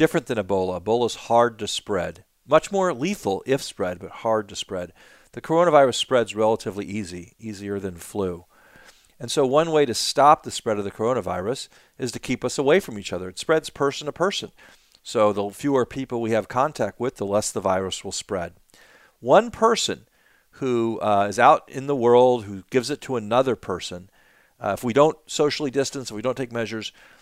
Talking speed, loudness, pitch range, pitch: 195 wpm, -23 LUFS, 100-140 Hz, 120 Hz